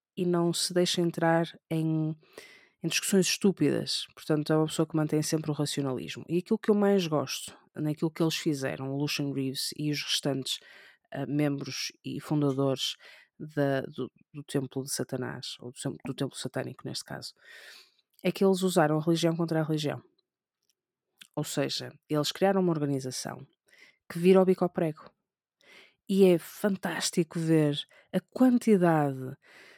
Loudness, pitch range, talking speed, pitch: -29 LUFS, 140-180 Hz, 155 wpm, 155 Hz